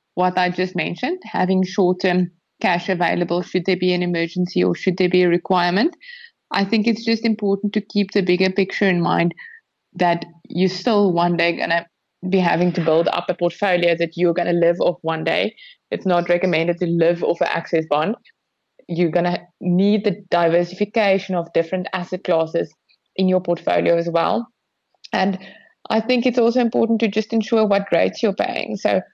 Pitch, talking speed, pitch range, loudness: 180 Hz, 180 wpm, 175-205 Hz, -19 LUFS